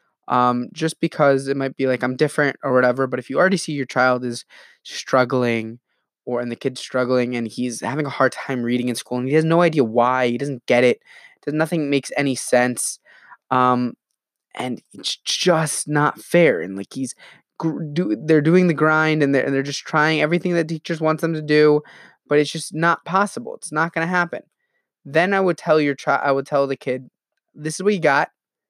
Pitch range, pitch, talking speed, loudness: 125-160 Hz, 145 Hz, 215 wpm, -20 LUFS